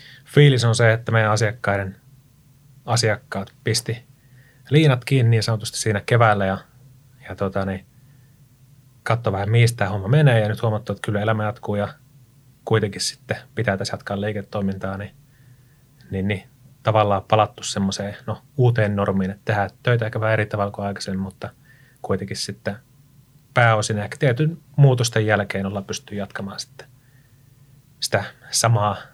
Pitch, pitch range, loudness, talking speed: 115 Hz, 105-130 Hz, -21 LUFS, 140 wpm